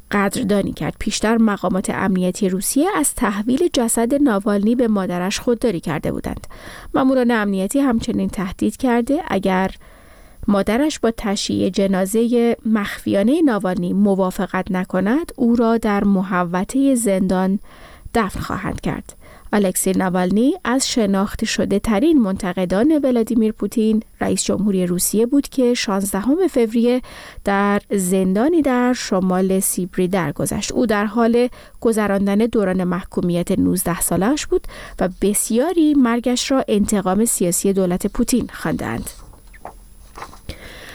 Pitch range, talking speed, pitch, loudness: 190-240 Hz, 115 wpm, 210 Hz, -18 LUFS